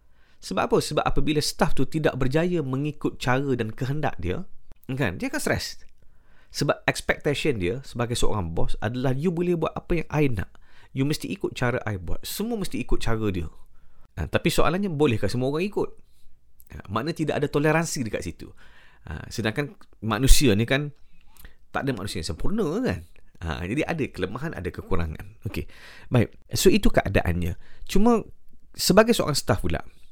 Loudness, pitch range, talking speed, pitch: -26 LUFS, 95-150 Hz, 165 wpm, 125 Hz